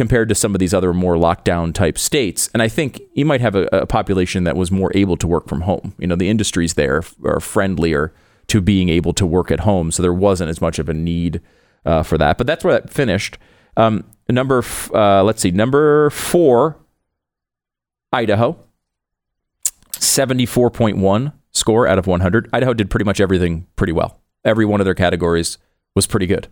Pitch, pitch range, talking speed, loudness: 95 Hz, 85-110 Hz, 190 wpm, -17 LUFS